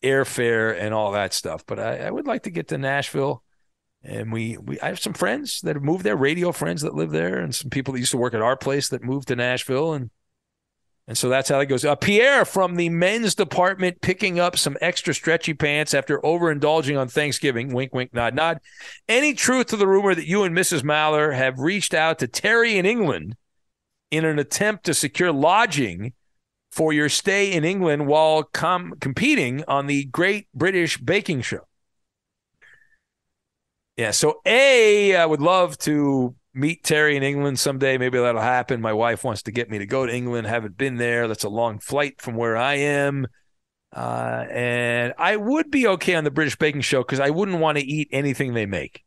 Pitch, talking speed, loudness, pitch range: 145 Hz, 200 wpm, -21 LUFS, 125-175 Hz